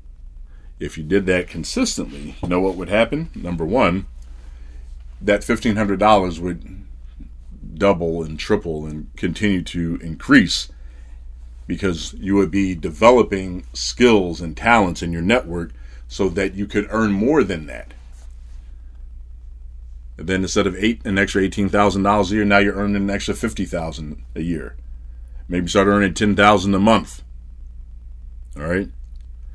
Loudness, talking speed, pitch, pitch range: -19 LUFS, 150 wpm, 85 Hz, 60-100 Hz